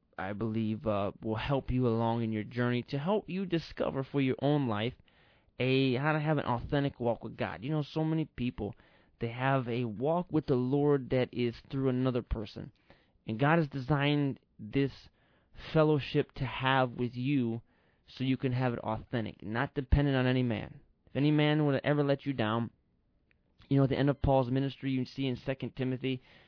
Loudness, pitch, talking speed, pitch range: -32 LUFS, 130 Hz, 195 wpm, 115-140 Hz